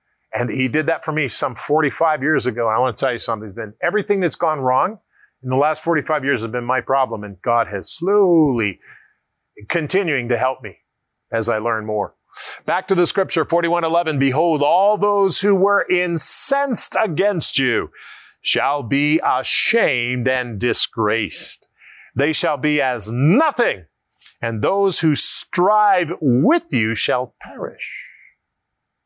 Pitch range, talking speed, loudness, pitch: 125-175 Hz, 155 wpm, -18 LUFS, 150 Hz